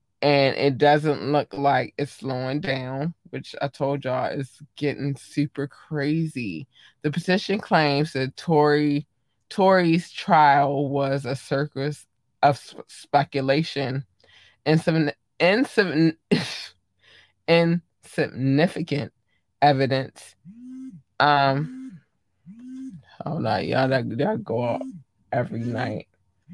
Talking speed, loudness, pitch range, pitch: 95 wpm, -23 LUFS, 130-155 Hz, 140 Hz